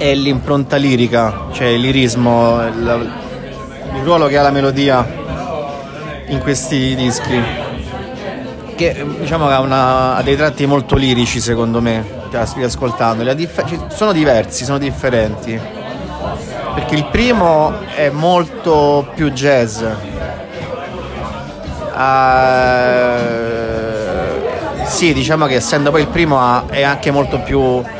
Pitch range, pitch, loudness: 120-145 Hz, 130 Hz, -14 LUFS